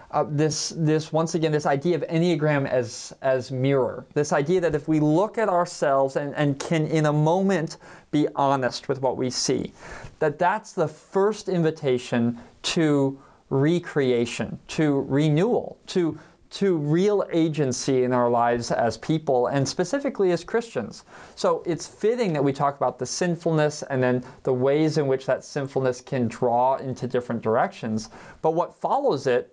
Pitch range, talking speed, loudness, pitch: 130-170 Hz, 165 wpm, -24 LUFS, 150 Hz